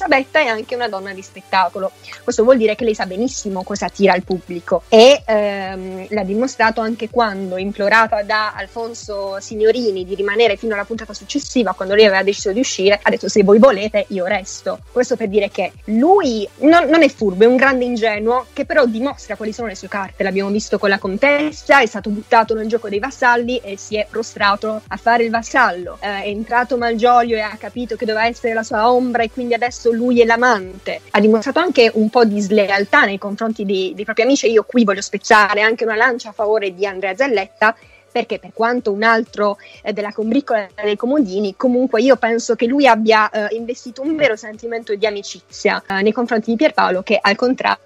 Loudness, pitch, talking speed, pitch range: -16 LUFS, 220 Hz, 205 wpm, 205-240 Hz